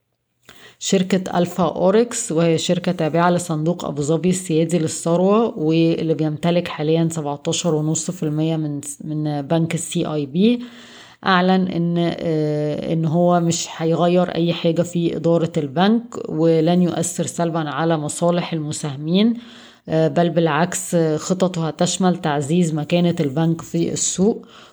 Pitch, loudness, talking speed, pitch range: 170 Hz, -19 LUFS, 120 wpm, 160-175 Hz